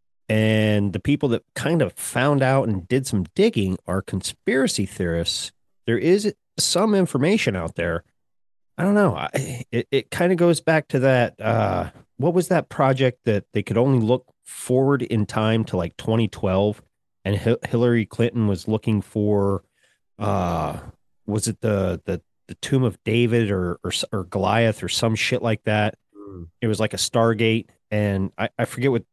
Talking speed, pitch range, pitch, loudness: 175 wpm, 100-125 Hz, 110 Hz, -22 LUFS